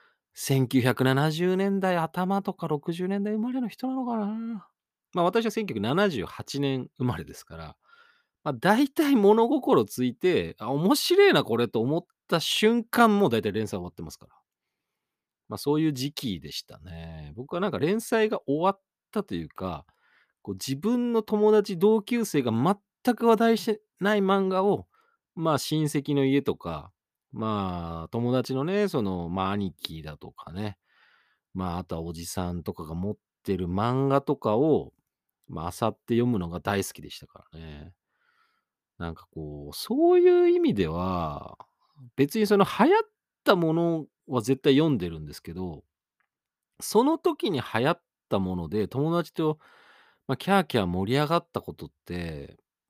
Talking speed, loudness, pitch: 275 characters per minute, -26 LUFS, 150 Hz